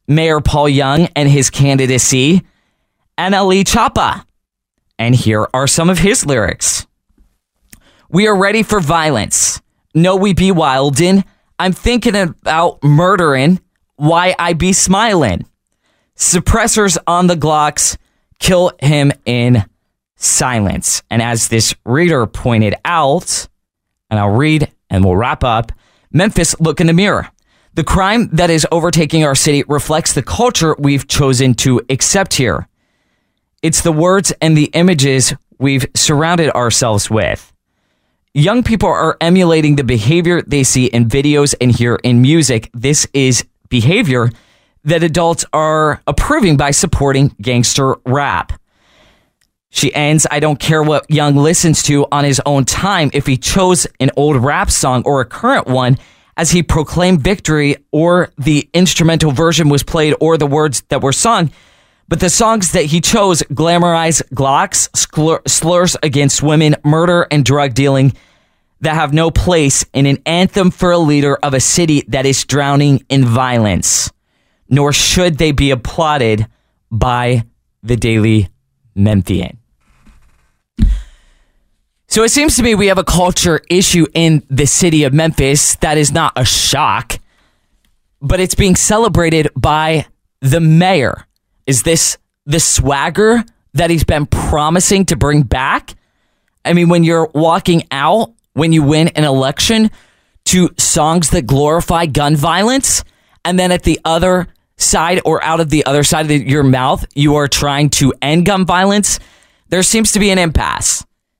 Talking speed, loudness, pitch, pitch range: 145 wpm, -12 LUFS, 155 Hz, 135-175 Hz